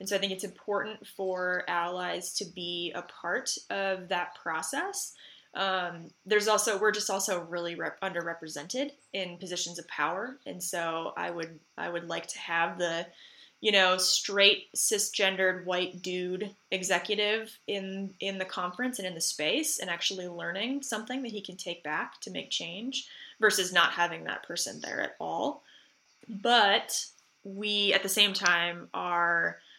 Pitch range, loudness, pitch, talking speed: 175-205 Hz, -30 LUFS, 190 Hz, 160 wpm